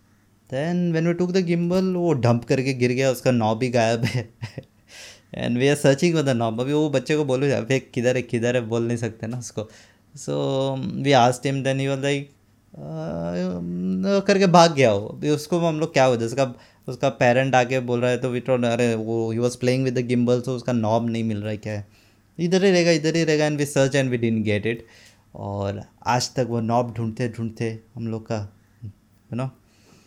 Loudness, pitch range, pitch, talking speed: -22 LUFS, 110-135 Hz, 125 Hz, 220 wpm